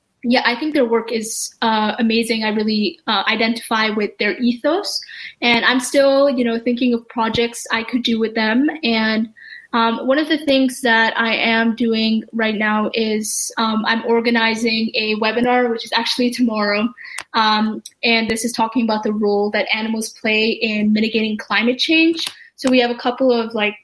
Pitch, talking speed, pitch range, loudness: 230 Hz, 180 wpm, 220-245 Hz, -17 LUFS